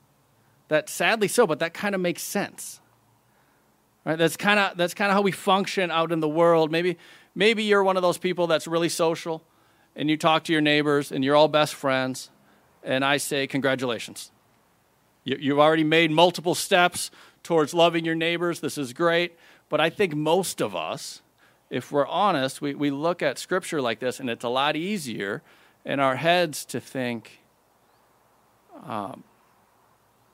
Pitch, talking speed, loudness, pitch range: 165 Hz, 175 wpm, -24 LUFS, 145-175 Hz